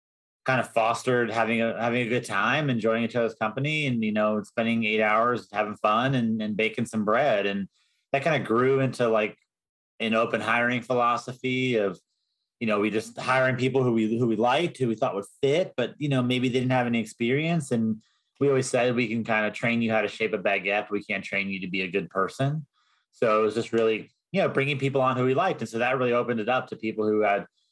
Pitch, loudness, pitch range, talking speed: 115 Hz, -25 LUFS, 110-125 Hz, 240 wpm